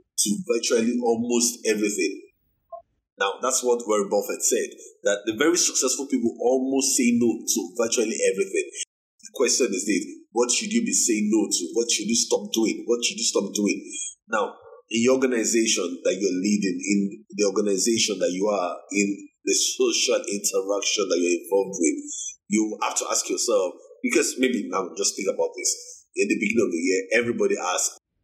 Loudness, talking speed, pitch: -23 LUFS, 175 wpm, 305 Hz